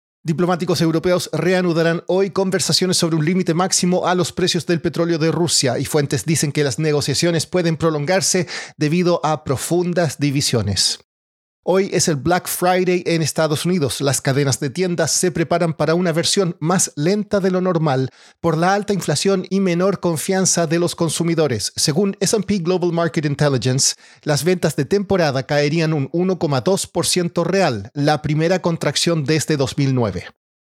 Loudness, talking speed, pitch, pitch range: -18 LUFS, 155 wpm, 170 Hz, 150-180 Hz